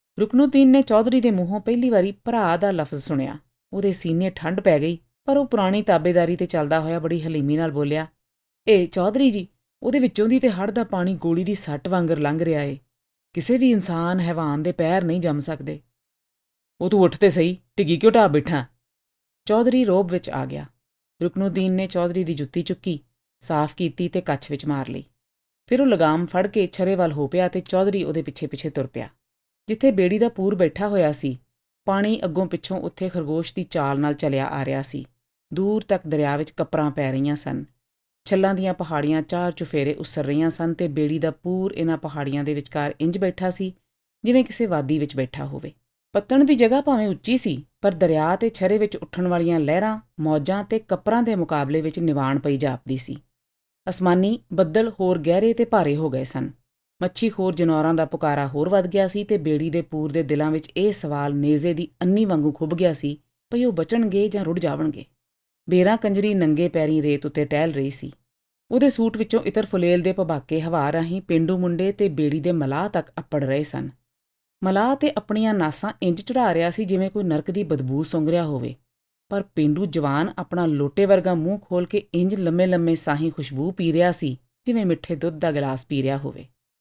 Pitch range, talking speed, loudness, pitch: 150-195 Hz, 195 wpm, -22 LUFS, 170 Hz